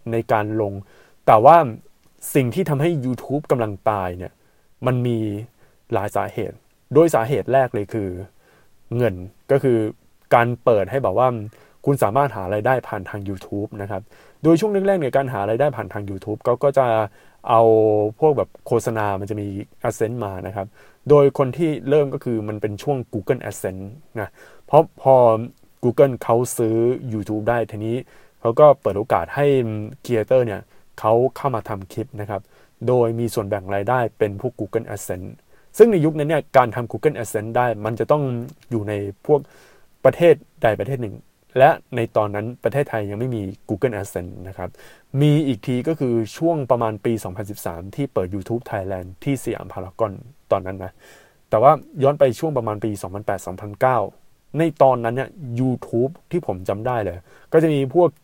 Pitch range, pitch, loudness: 105-135 Hz, 115 Hz, -20 LUFS